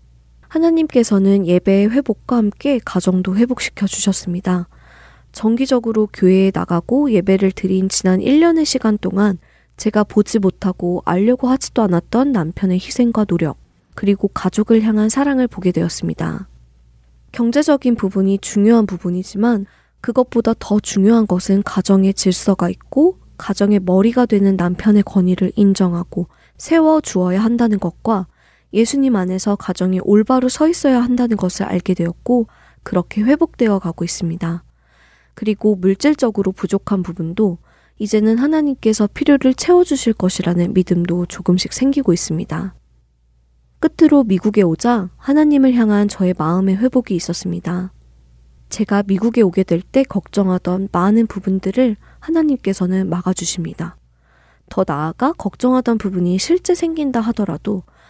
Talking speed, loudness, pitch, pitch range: 325 characters per minute, -16 LUFS, 200 Hz, 180-235 Hz